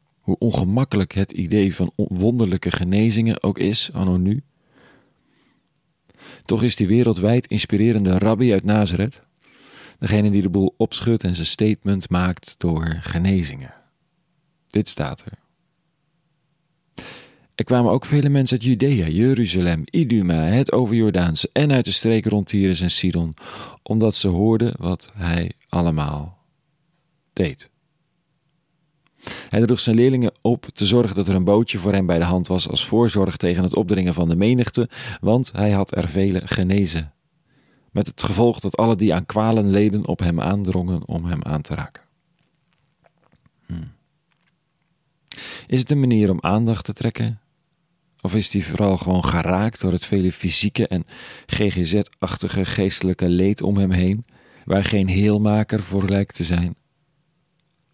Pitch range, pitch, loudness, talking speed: 95-130 Hz, 105 Hz, -20 LUFS, 145 wpm